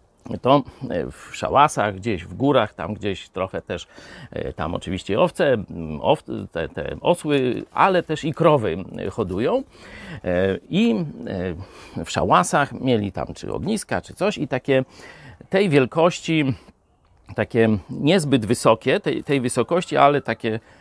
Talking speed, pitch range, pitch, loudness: 125 wpm, 105-150 Hz, 125 Hz, -22 LUFS